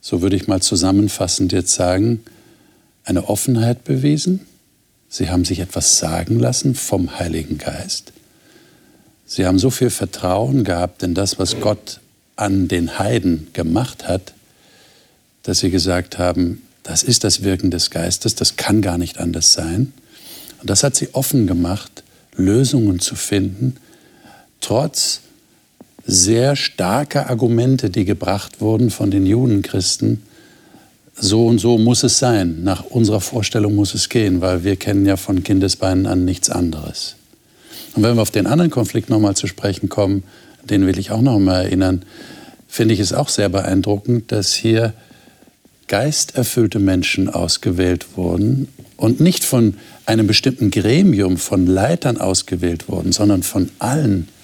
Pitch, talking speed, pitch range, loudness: 100 Hz, 145 wpm, 90-115 Hz, -17 LUFS